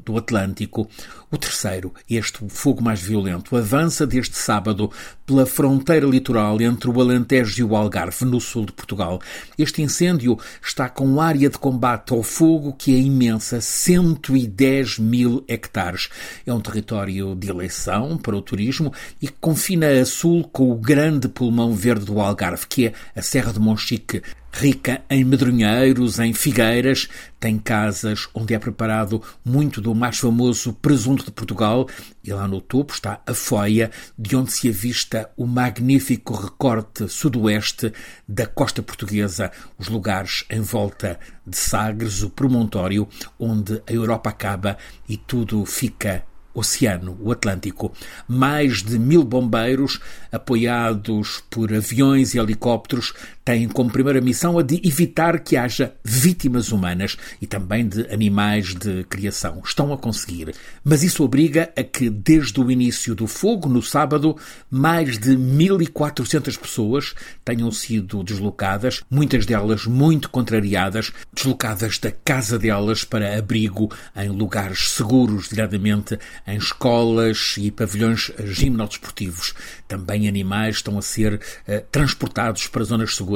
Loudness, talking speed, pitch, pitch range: -20 LUFS, 140 wpm, 115 Hz, 105-130 Hz